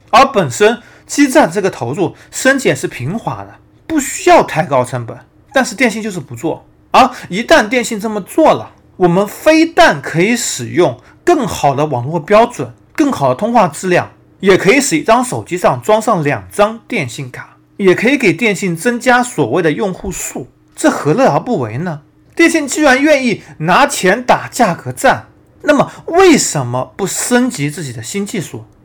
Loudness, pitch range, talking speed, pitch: -13 LUFS, 155-265 Hz, 260 characters per minute, 210 Hz